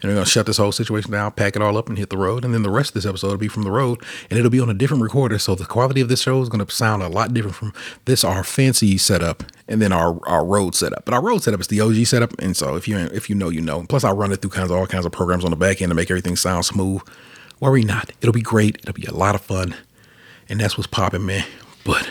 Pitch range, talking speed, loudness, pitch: 95-115 Hz, 305 wpm, -19 LUFS, 100 Hz